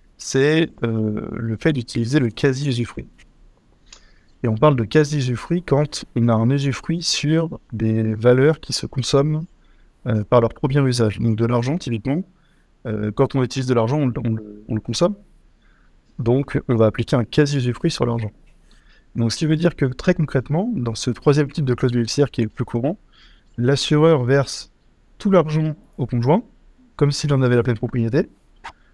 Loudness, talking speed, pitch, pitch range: -20 LUFS, 175 wpm, 130 Hz, 115-150 Hz